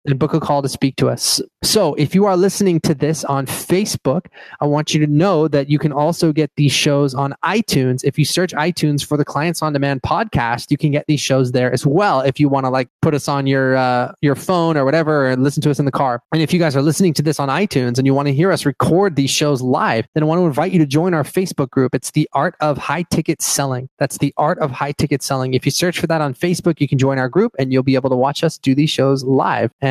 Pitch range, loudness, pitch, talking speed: 135-160 Hz, -16 LUFS, 145 Hz, 280 wpm